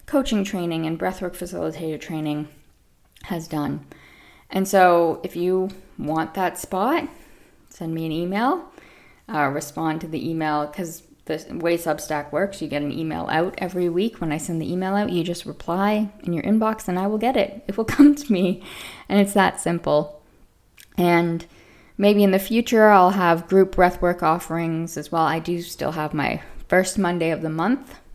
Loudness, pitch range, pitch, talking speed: -22 LUFS, 160-195 Hz, 175 Hz, 180 wpm